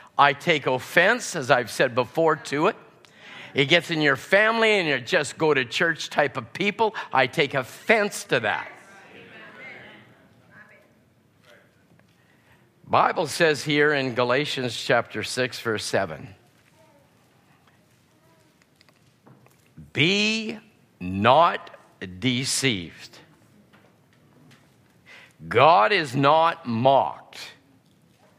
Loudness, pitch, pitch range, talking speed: -22 LUFS, 145 Hz, 125-175 Hz, 95 wpm